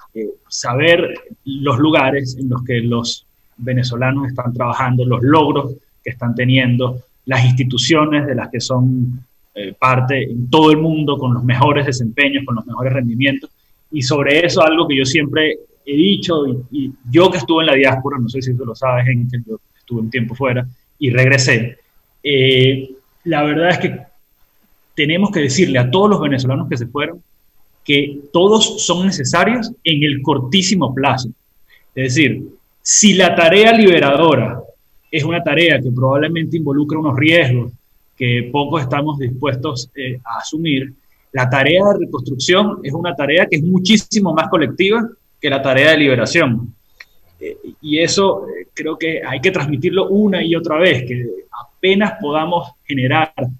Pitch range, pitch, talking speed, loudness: 125-165 Hz, 140 Hz, 165 wpm, -15 LUFS